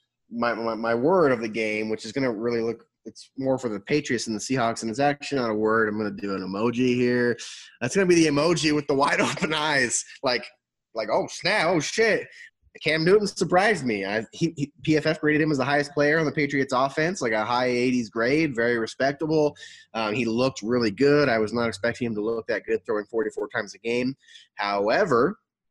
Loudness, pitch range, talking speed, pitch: -24 LUFS, 115-150 Hz, 220 wpm, 125 Hz